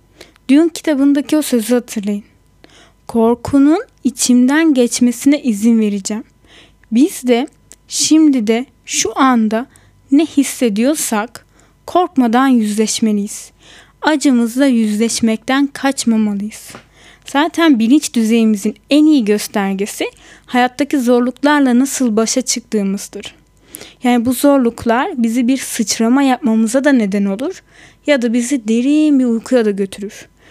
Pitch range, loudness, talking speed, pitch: 225-280 Hz, -14 LUFS, 100 wpm, 245 Hz